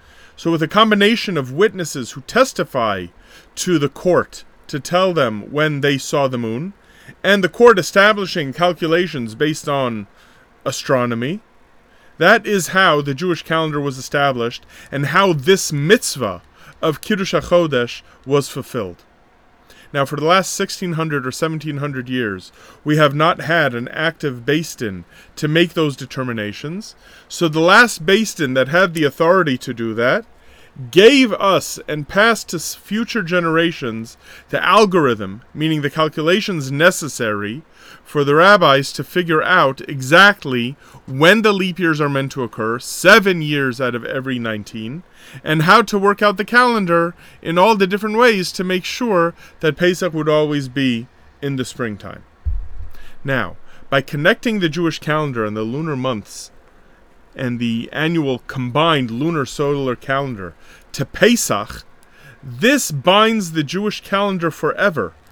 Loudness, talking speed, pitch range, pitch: -16 LUFS, 145 wpm, 130-185 Hz, 155 Hz